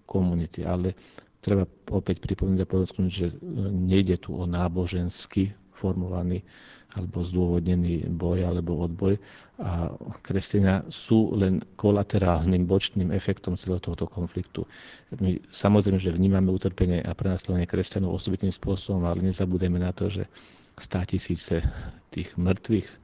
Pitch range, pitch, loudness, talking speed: 90-95 Hz, 95 Hz, -27 LUFS, 120 wpm